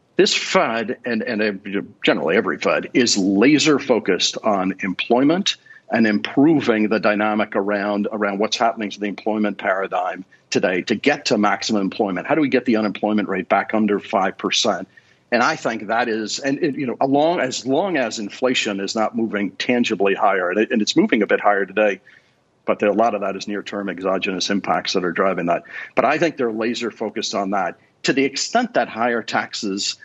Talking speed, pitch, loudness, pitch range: 190 wpm, 105 Hz, -20 LUFS, 100-115 Hz